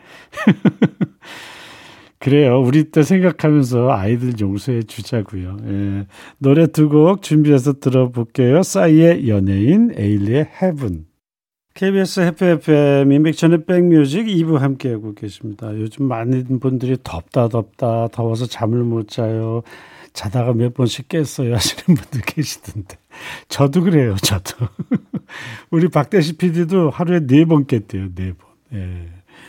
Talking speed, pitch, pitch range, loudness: 270 characters per minute, 130 Hz, 110-155 Hz, -16 LUFS